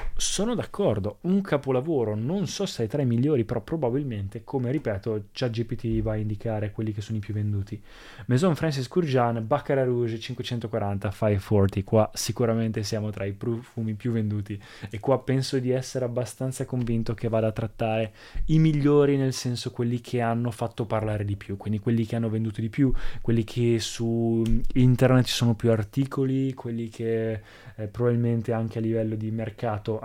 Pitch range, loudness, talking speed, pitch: 110-125 Hz, -26 LUFS, 175 wpm, 115 Hz